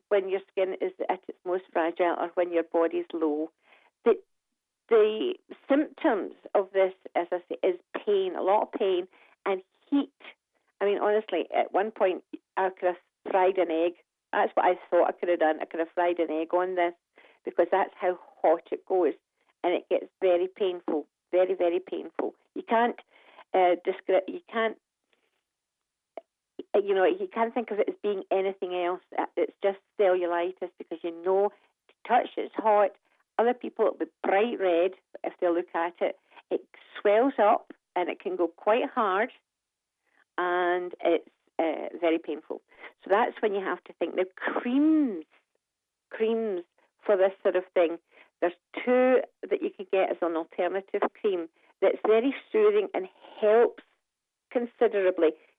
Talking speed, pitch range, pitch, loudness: 165 wpm, 175-275 Hz, 195 Hz, -28 LUFS